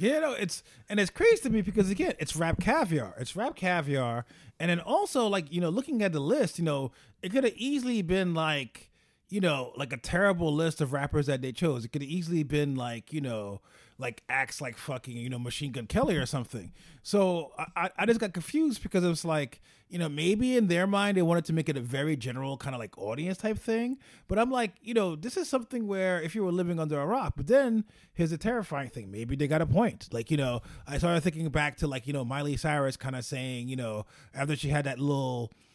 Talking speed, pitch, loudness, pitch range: 240 wpm, 155 Hz, -30 LUFS, 135-200 Hz